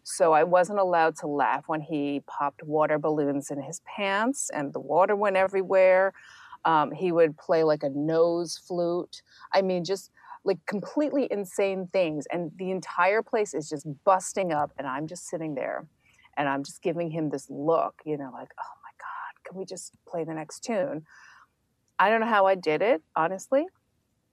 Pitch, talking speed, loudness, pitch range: 175 Hz, 185 wpm, -26 LUFS, 155-195 Hz